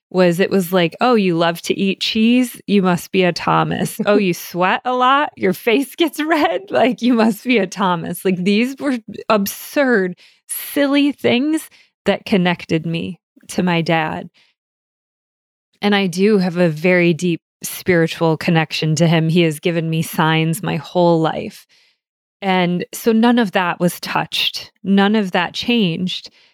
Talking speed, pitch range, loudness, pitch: 165 wpm, 175-230 Hz, -17 LUFS, 190 Hz